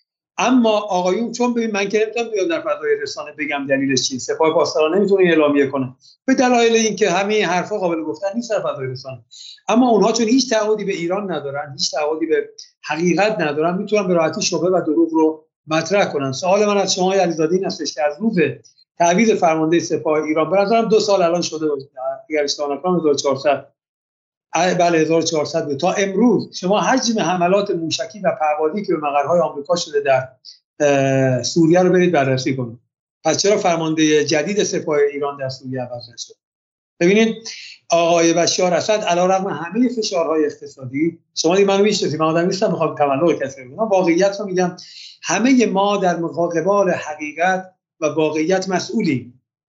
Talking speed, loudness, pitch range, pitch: 160 wpm, -18 LUFS, 150-200 Hz, 170 Hz